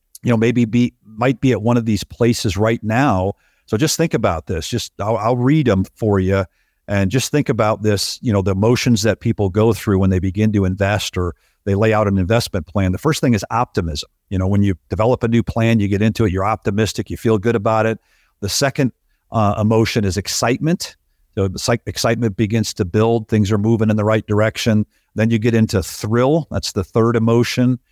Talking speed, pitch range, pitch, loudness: 215 wpm, 100-120 Hz, 110 Hz, -17 LUFS